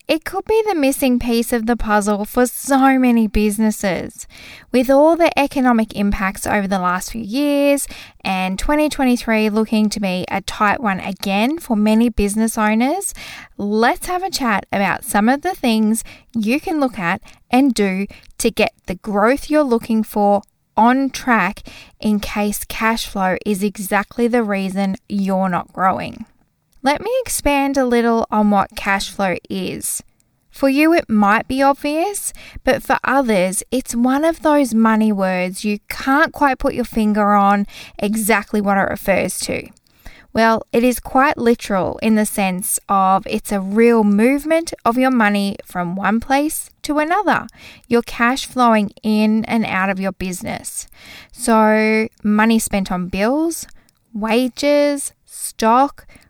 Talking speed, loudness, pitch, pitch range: 155 wpm, -17 LUFS, 225 Hz, 205-265 Hz